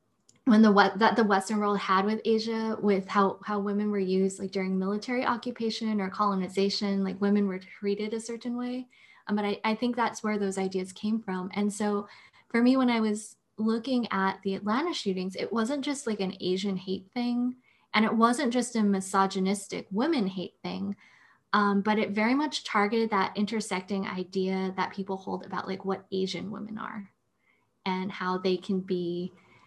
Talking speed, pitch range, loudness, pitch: 185 wpm, 190-225 Hz, -28 LUFS, 205 Hz